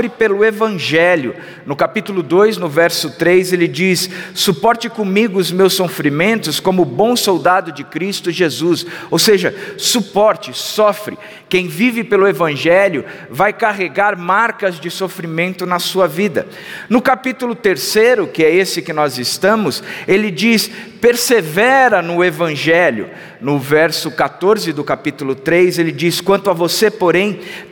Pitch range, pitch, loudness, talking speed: 170-210 Hz, 185 Hz, -14 LUFS, 135 wpm